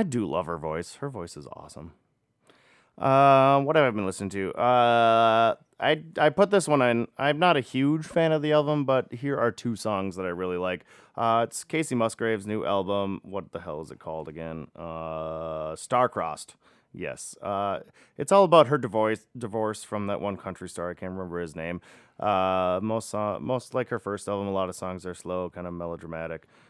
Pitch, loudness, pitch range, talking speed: 105 Hz, -26 LUFS, 90-130 Hz, 205 wpm